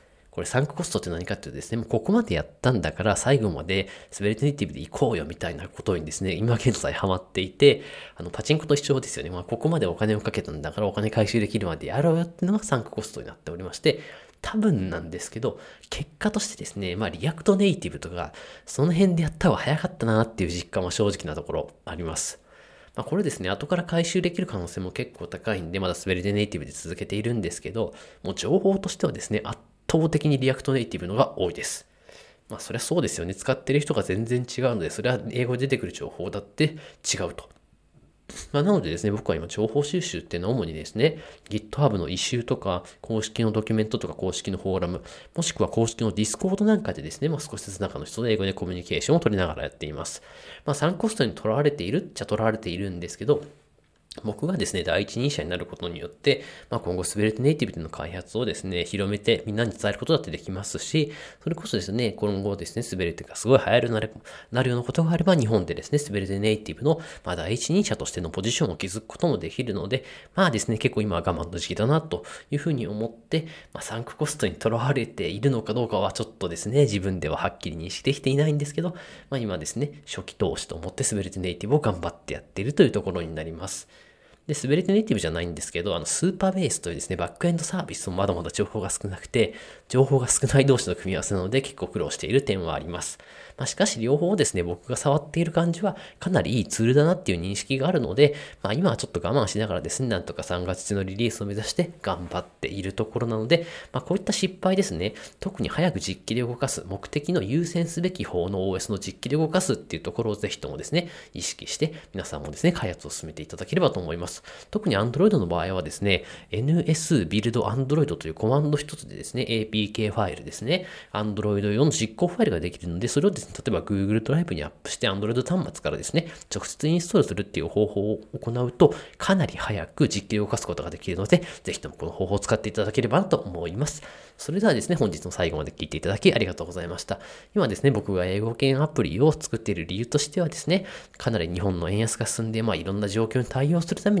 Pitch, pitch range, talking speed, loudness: 110 Hz, 95-145 Hz, 510 characters per minute, -26 LUFS